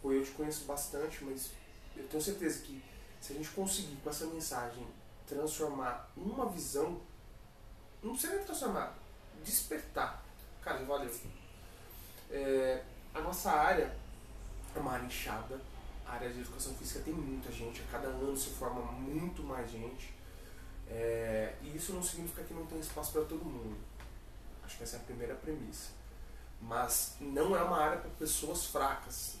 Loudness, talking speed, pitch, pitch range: -38 LUFS, 155 wpm, 130 Hz, 110-155 Hz